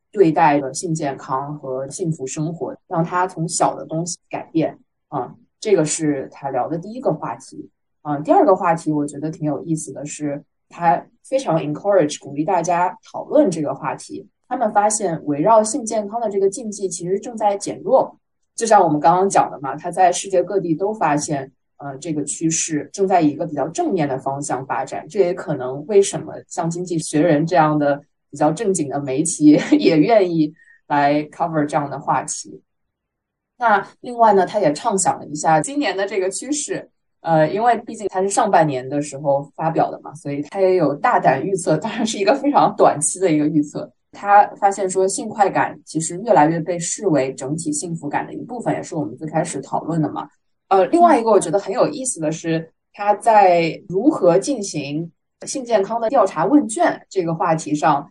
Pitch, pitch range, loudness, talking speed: 170 Hz, 150-200 Hz, -19 LUFS, 300 characters per minute